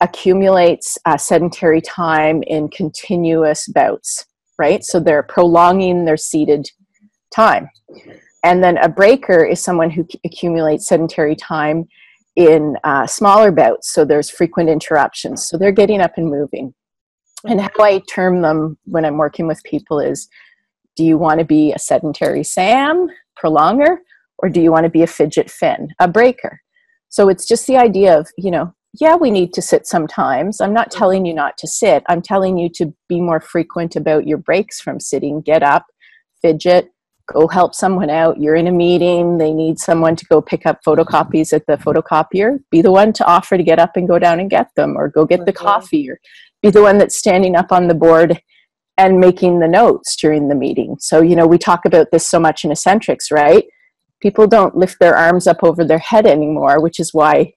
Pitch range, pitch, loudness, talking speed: 160-195 Hz, 175 Hz, -13 LUFS, 195 wpm